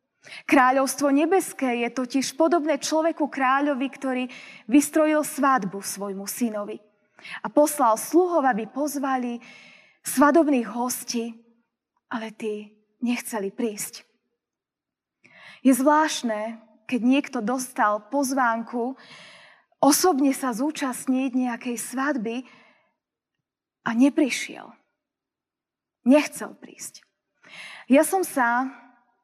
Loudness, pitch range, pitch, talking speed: -23 LUFS, 230-285 Hz, 255 Hz, 85 wpm